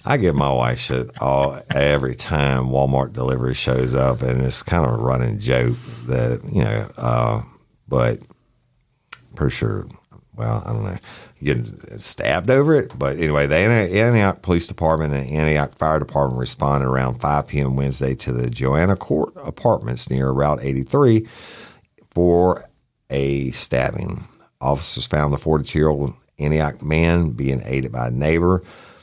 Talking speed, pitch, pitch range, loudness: 145 wpm, 70 Hz, 65-85 Hz, -20 LUFS